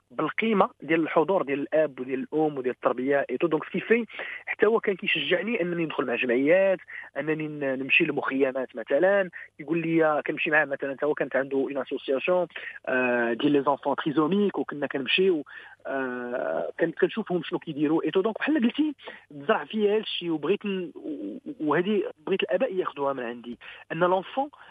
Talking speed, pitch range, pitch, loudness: 145 wpm, 140-210 Hz, 165 Hz, -26 LUFS